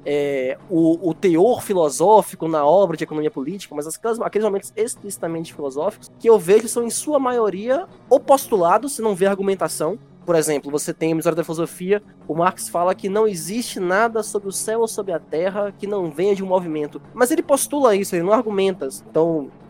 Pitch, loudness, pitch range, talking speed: 190 Hz, -20 LUFS, 160-215 Hz, 195 wpm